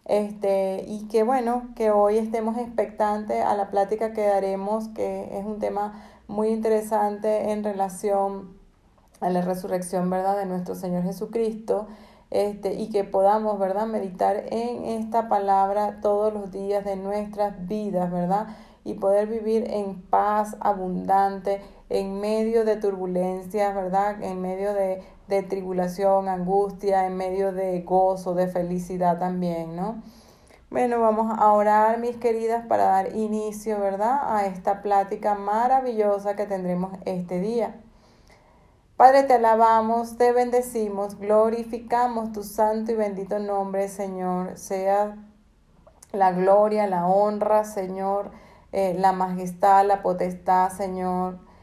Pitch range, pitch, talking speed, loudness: 195-215 Hz, 200 Hz, 130 wpm, -24 LUFS